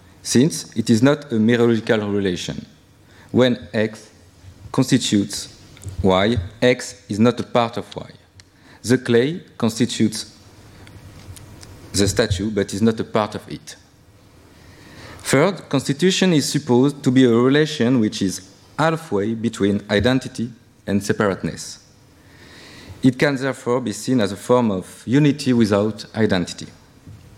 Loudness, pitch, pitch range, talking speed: -19 LUFS, 110 Hz, 100-125 Hz, 125 wpm